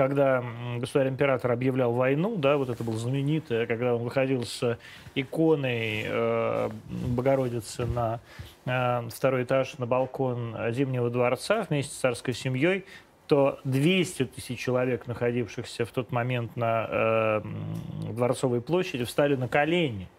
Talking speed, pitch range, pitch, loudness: 130 wpm, 120-135 Hz, 125 Hz, -27 LUFS